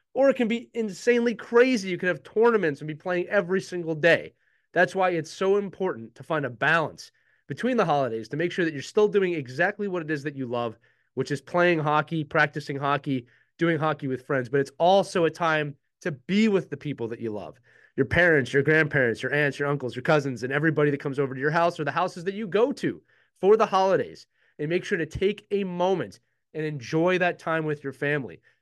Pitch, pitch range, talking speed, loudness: 160 Hz, 145-185 Hz, 225 wpm, -25 LUFS